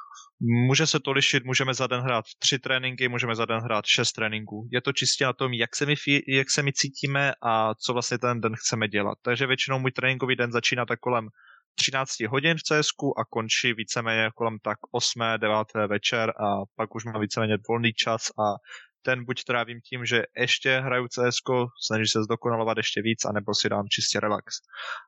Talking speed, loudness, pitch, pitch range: 195 wpm, -25 LUFS, 120 Hz, 110-130 Hz